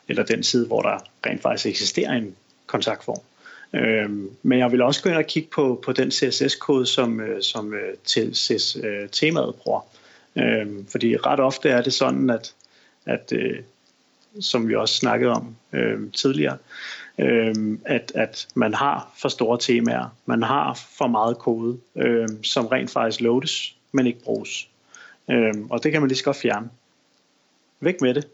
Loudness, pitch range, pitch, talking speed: -22 LUFS, 110-130 Hz, 120 Hz, 140 wpm